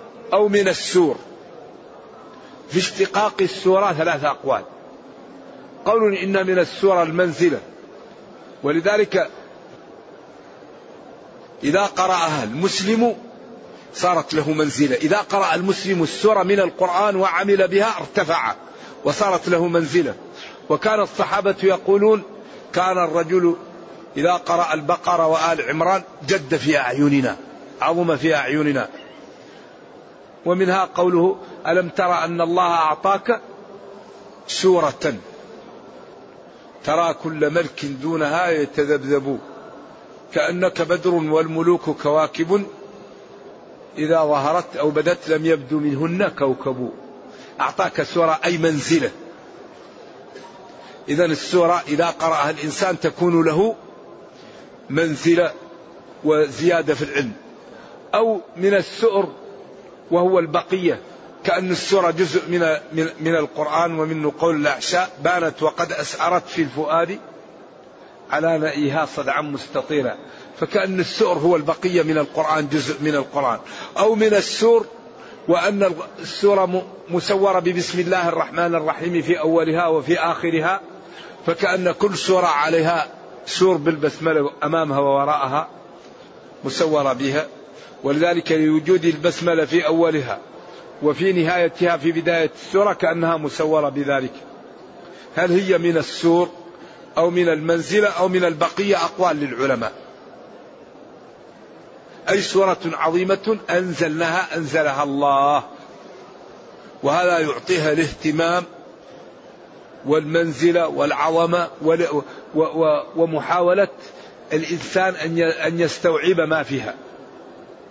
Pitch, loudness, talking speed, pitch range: 170 Hz, -19 LUFS, 95 wpm, 155-185 Hz